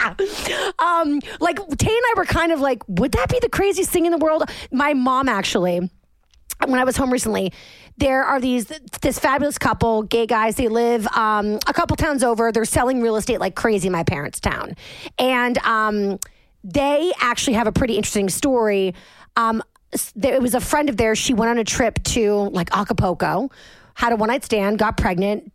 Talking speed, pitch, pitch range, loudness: 195 wpm, 235 Hz, 215-275 Hz, -20 LUFS